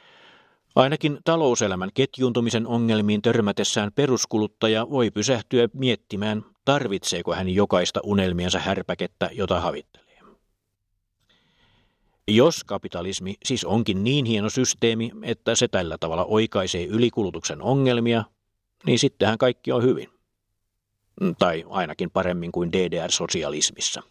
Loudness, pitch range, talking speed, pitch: -23 LUFS, 95-120 Hz, 100 wpm, 105 Hz